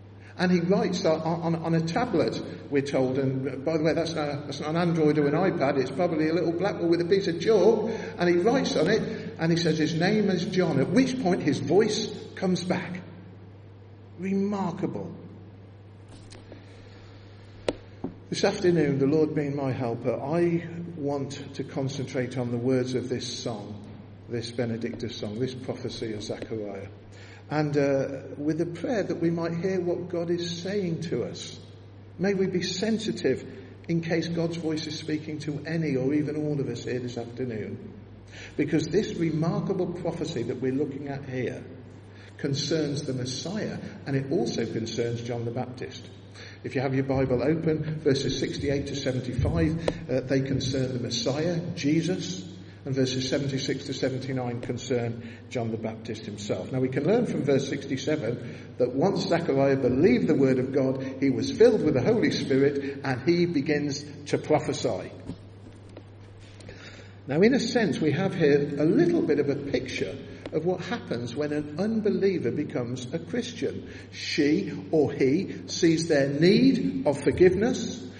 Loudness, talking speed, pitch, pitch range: -27 LUFS, 165 wpm, 140 Hz, 120-165 Hz